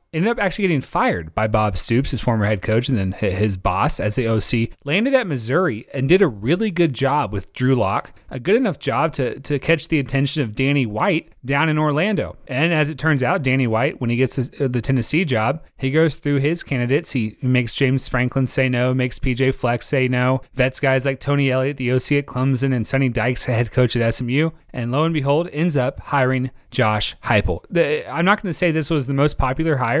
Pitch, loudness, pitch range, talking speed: 130 Hz, -20 LUFS, 125-150 Hz, 230 wpm